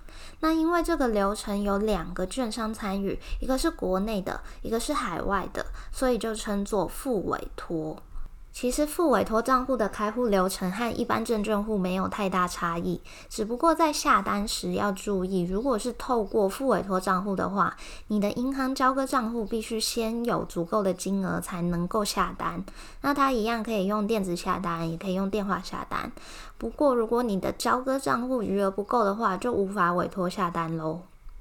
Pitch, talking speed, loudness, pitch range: 210 Hz, 275 characters per minute, -27 LUFS, 185-245 Hz